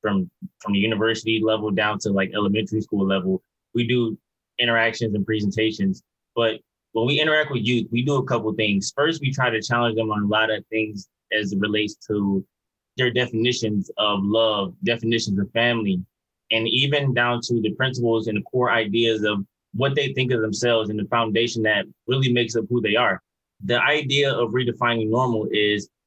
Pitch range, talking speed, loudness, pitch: 105-120 Hz, 190 wpm, -22 LUFS, 115 Hz